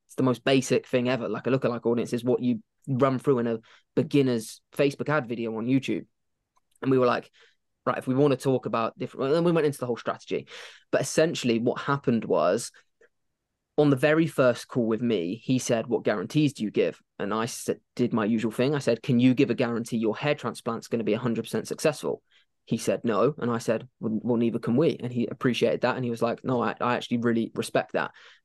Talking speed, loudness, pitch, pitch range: 230 wpm, -26 LUFS, 120 Hz, 115-135 Hz